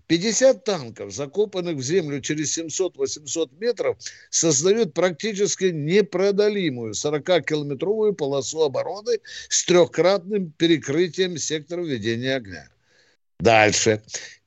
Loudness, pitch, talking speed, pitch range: -22 LUFS, 170 Hz, 85 wpm, 145-205 Hz